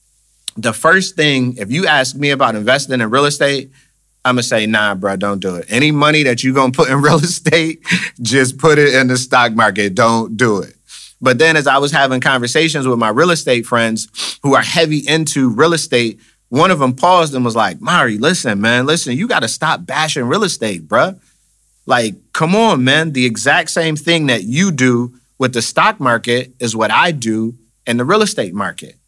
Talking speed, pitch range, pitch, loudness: 210 wpm, 115-155 Hz, 130 Hz, -13 LUFS